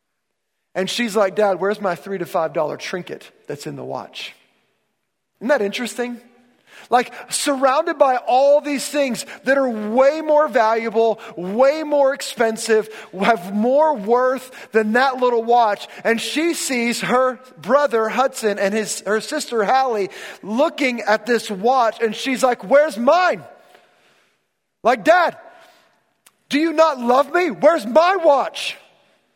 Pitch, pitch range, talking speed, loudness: 245 Hz, 220-285 Hz, 140 wpm, -18 LUFS